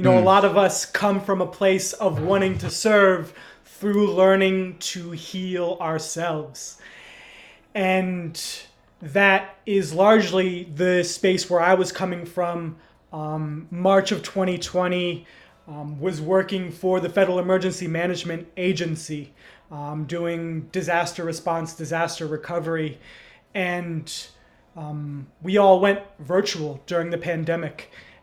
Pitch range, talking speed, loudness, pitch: 165-190 Hz, 125 wpm, -22 LUFS, 175 Hz